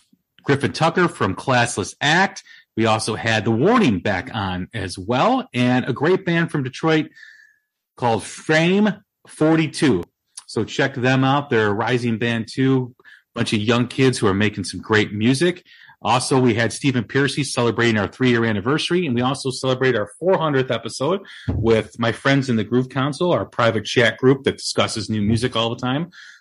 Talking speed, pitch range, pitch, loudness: 175 wpm, 115-140 Hz, 125 Hz, -20 LUFS